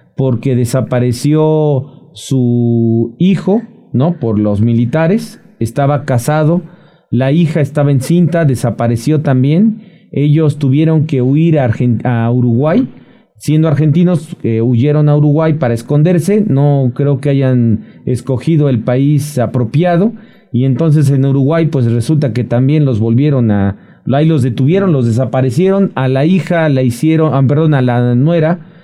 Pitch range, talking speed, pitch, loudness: 125-160 Hz, 135 wpm, 140 Hz, -12 LUFS